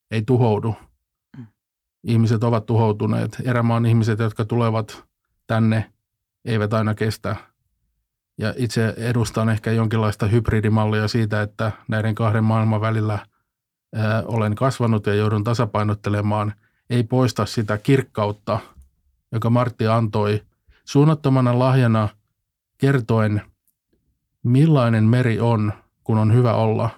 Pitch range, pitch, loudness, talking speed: 105-115 Hz, 110 Hz, -20 LUFS, 105 wpm